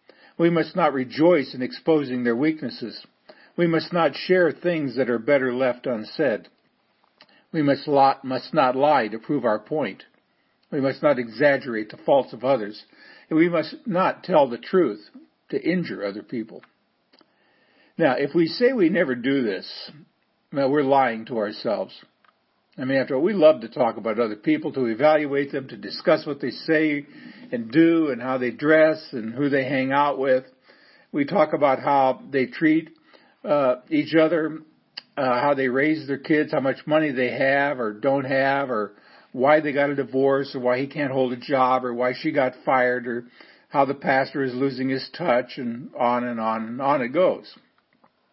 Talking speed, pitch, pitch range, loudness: 185 wpm, 140 Hz, 130-155 Hz, -22 LUFS